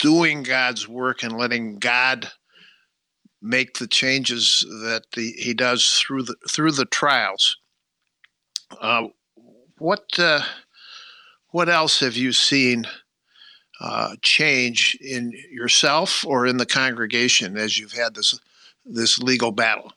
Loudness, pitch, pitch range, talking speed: -19 LUFS, 125 Hz, 115-130 Hz, 125 wpm